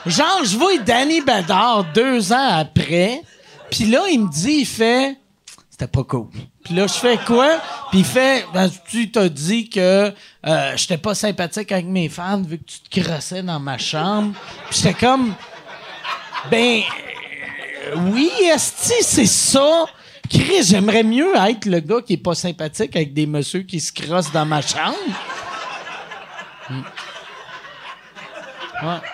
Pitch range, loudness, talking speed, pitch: 175-245 Hz, -17 LUFS, 155 wpm, 200 Hz